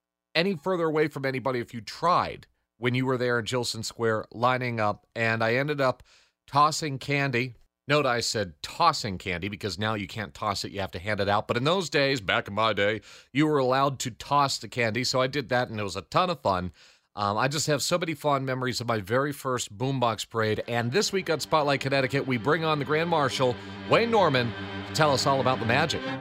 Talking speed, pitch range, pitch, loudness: 230 wpm, 110-140 Hz, 125 Hz, -26 LUFS